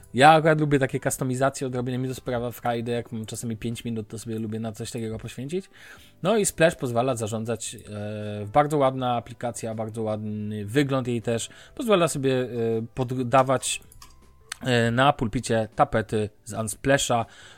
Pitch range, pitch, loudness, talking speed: 110-135 Hz, 120 Hz, -25 LUFS, 145 wpm